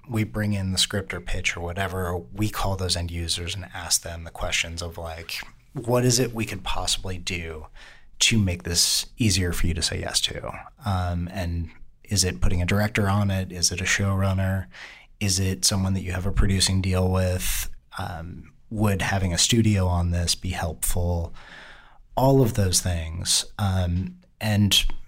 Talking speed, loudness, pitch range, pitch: 180 wpm, -24 LUFS, 85-100 Hz, 95 Hz